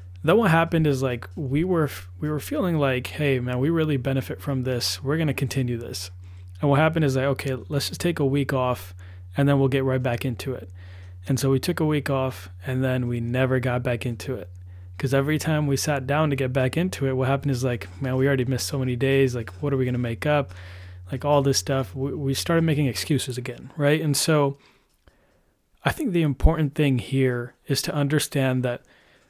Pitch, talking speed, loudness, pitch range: 135 Hz, 225 wpm, -24 LUFS, 125-145 Hz